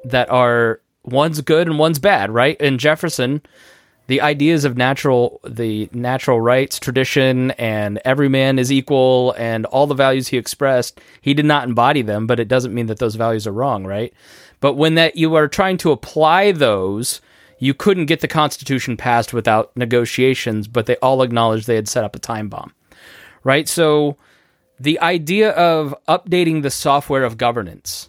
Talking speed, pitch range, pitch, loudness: 175 wpm, 120-150 Hz, 130 Hz, -16 LUFS